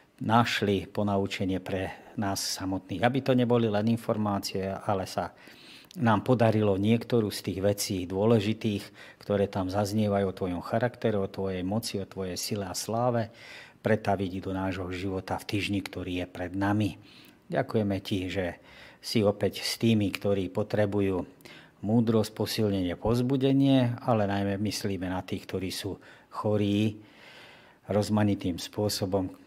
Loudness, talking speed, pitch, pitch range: -29 LUFS, 130 wpm, 100 Hz, 95-110 Hz